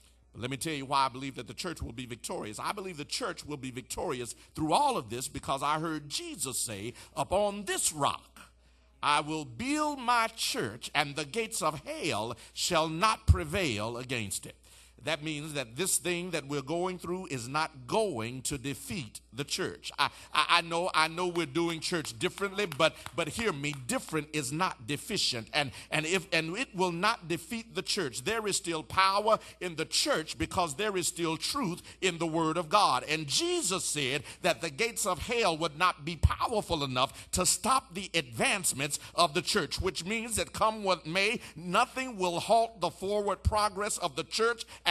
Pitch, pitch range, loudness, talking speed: 170 Hz, 145-195 Hz, -31 LUFS, 190 wpm